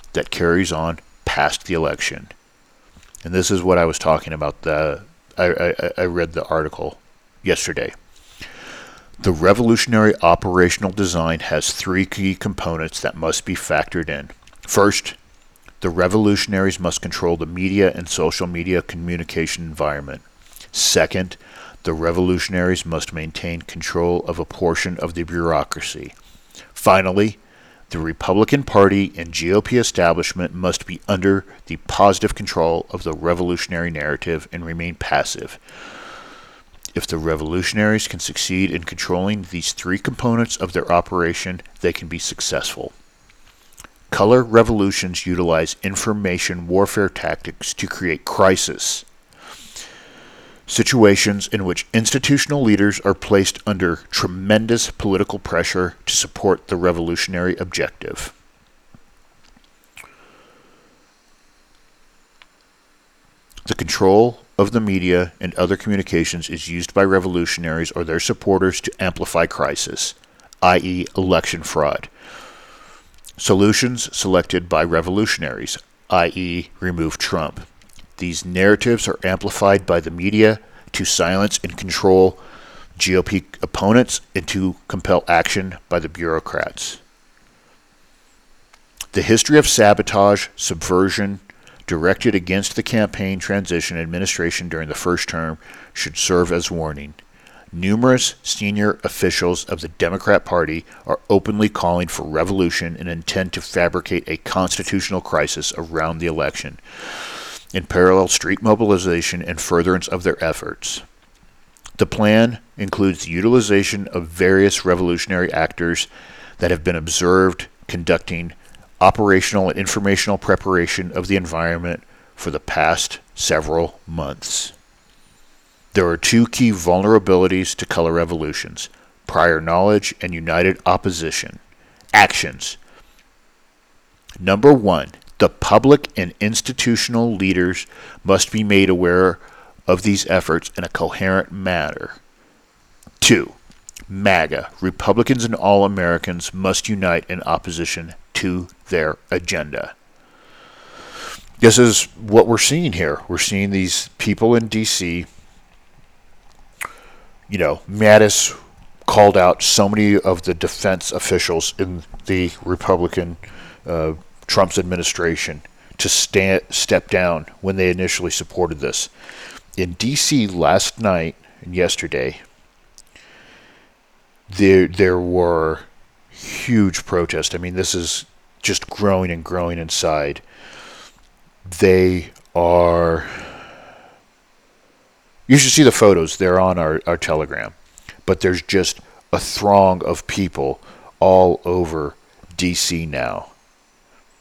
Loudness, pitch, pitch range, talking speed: -18 LUFS, 90 Hz, 85-100 Hz, 115 wpm